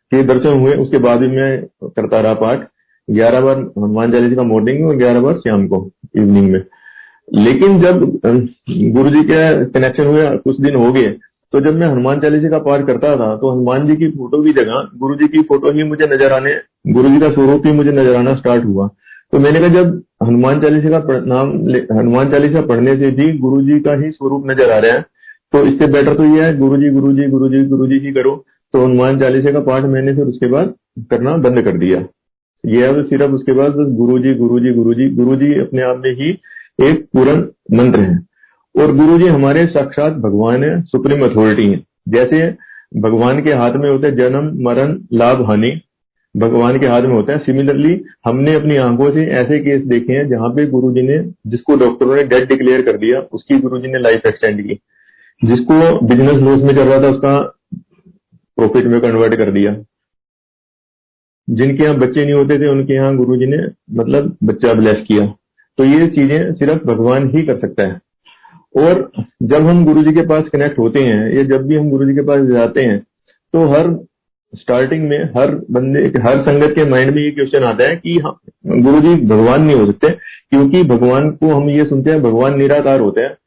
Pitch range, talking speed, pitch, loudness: 125-150 Hz, 200 wpm, 135 Hz, -12 LUFS